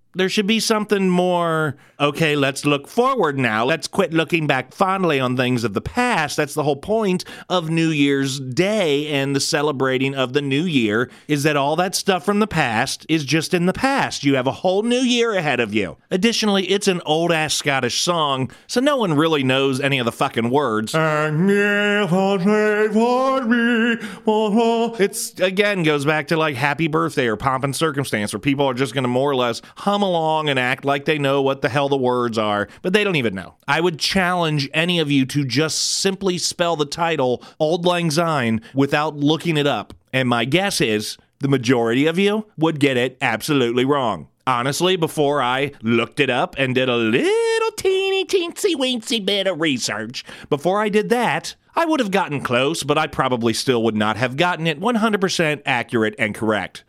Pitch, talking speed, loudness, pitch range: 155 Hz, 195 wpm, -19 LUFS, 135-195 Hz